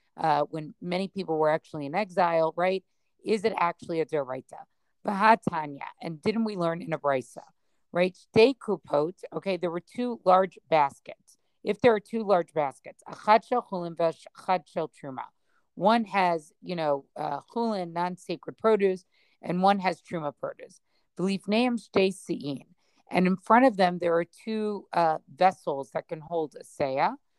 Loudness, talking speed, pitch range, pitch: -27 LUFS, 160 wpm, 160-205 Hz, 180 Hz